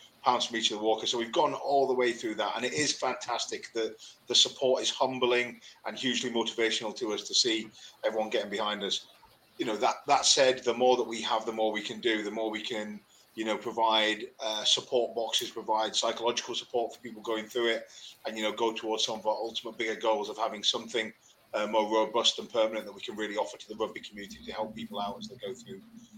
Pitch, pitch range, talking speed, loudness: 115 Hz, 110-120 Hz, 235 wpm, -29 LUFS